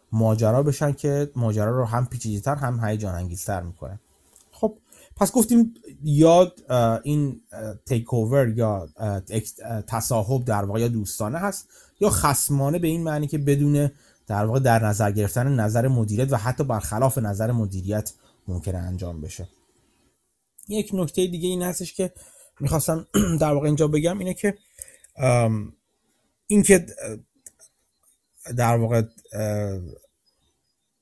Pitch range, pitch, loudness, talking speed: 105-155 Hz, 120 Hz, -22 LUFS, 130 wpm